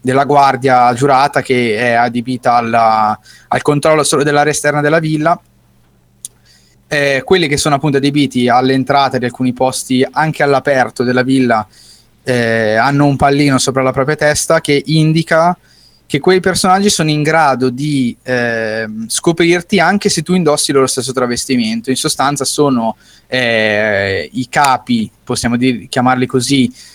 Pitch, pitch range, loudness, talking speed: 135 Hz, 125-150 Hz, -12 LUFS, 140 wpm